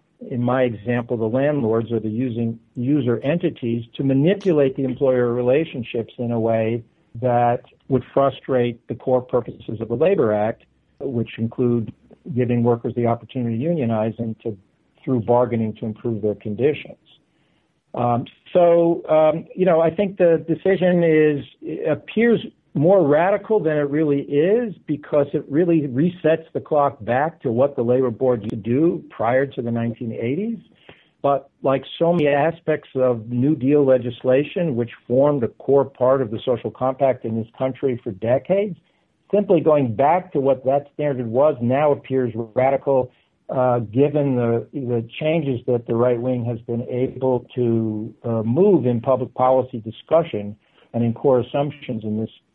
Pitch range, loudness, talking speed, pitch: 120-150 Hz, -20 LUFS, 160 wpm, 130 Hz